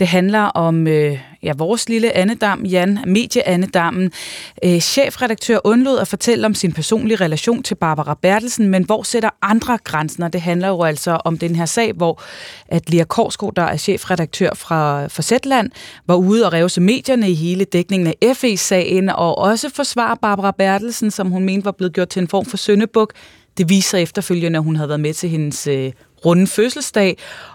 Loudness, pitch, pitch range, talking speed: -16 LUFS, 185 Hz, 170-220 Hz, 180 wpm